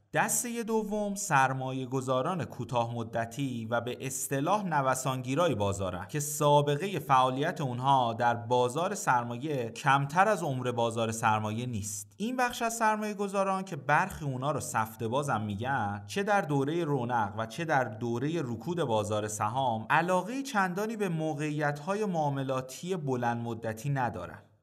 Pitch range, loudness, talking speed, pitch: 120-170 Hz, -30 LUFS, 130 wpm, 135 Hz